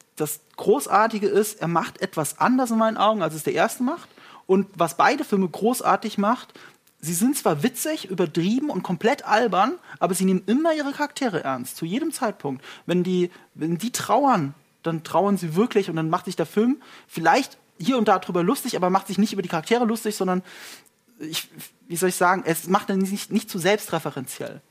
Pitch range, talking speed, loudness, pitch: 175-230 Hz, 195 wpm, -23 LUFS, 200 Hz